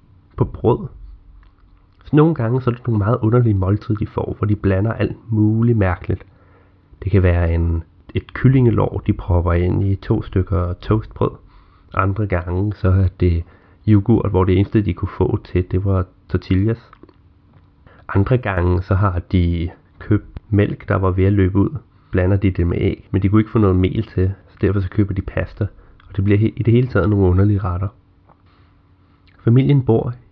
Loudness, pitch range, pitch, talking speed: -18 LUFS, 95-105 Hz, 95 Hz, 185 wpm